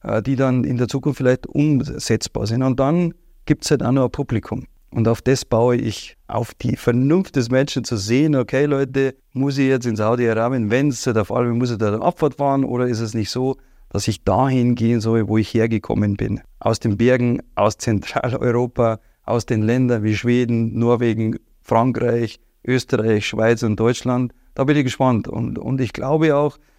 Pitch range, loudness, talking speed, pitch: 115-135 Hz, -19 LUFS, 190 wpm, 125 Hz